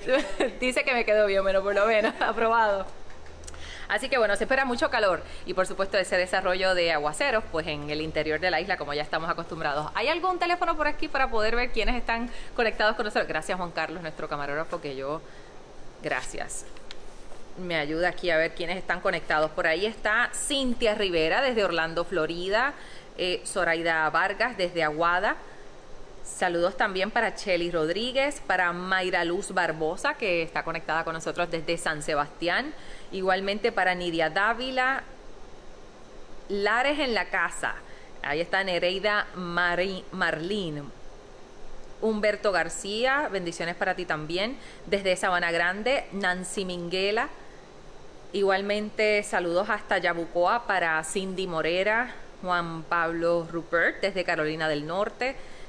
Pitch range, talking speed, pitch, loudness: 165-215 Hz, 140 wpm, 185 Hz, -26 LUFS